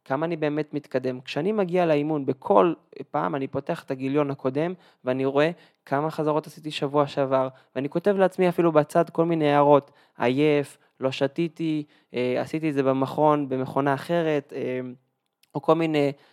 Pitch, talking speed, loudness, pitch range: 145 Hz, 150 wpm, -25 LUFS, 135-160 Hz